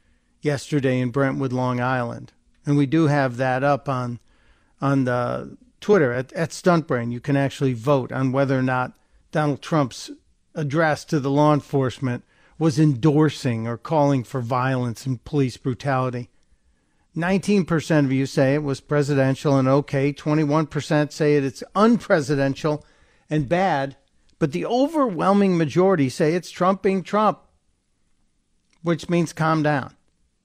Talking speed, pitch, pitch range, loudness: 145 wpm, 145 Hz, 130-160 Hz, -22 LUFS